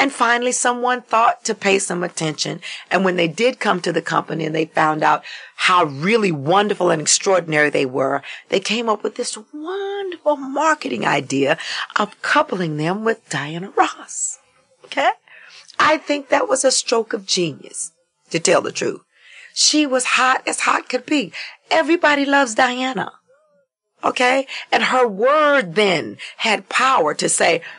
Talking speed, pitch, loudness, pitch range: 160 wpm, 235 Hz, -18 LUFS, 175-275 Hz